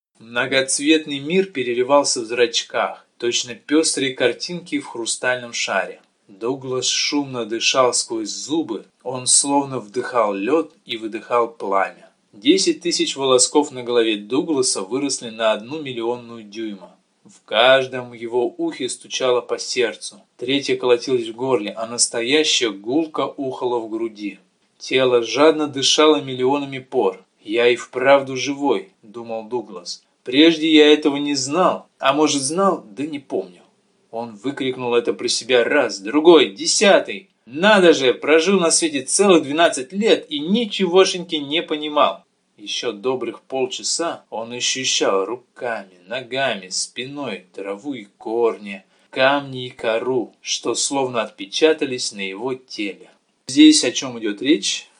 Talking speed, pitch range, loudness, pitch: 130 wpm, 125-170 Hz, -19 LUFS, 140 Hz